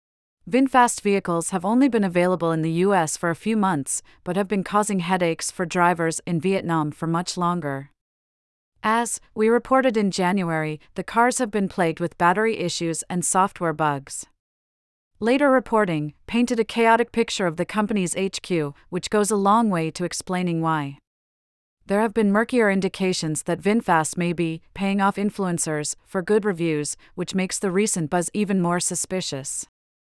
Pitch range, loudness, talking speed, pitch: 165-210 Hz, -22 LUFS, 165 wpm, 180 Hz